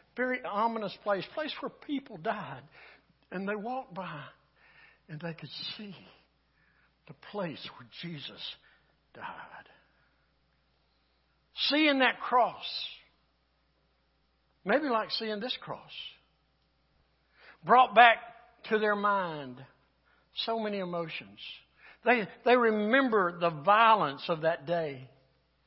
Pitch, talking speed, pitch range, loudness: 200 Hz, 105 wpm, 150-235 Hz, -29 LUFS